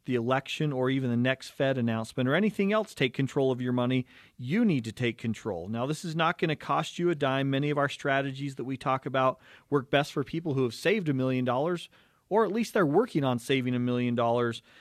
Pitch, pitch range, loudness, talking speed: 135 Hz, 125-155 Hz, -29 LUFS, 240 wpm